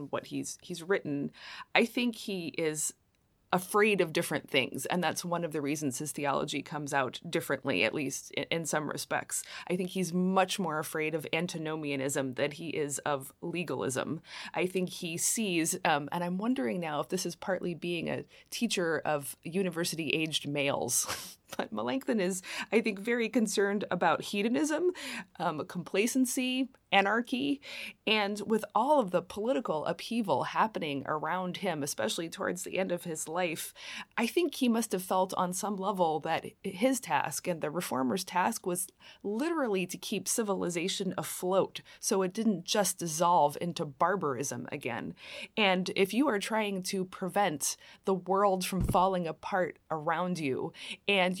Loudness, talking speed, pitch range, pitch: -32 LUFS, 160 wpm, 160-205 Hz, 185 Hz